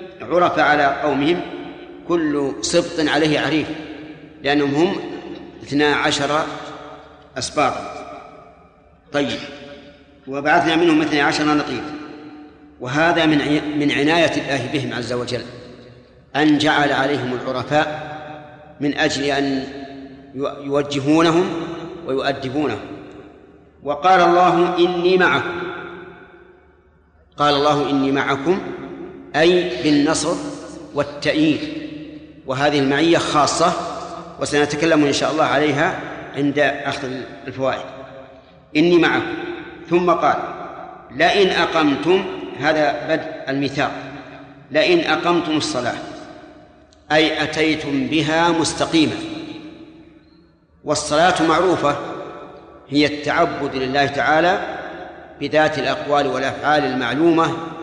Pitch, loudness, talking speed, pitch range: 150 Hz, -18 LUFS, 85 wpm, 140-175 Hz